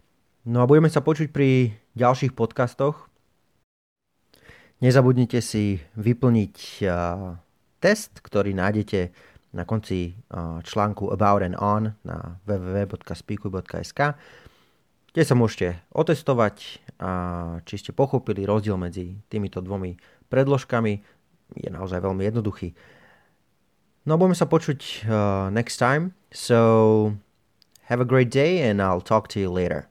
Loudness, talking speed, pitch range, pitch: -23 LUFS, 120 wpm, 95-125 Hz, 105 Hz